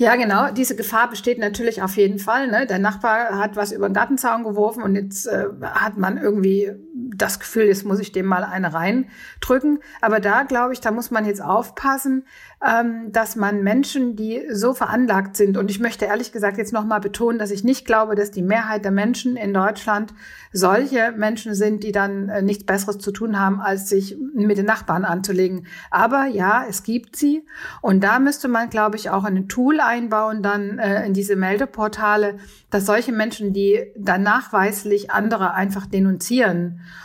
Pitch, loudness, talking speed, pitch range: 215 Hz, -20 LUFS, 185 wpm, 200-230 Hz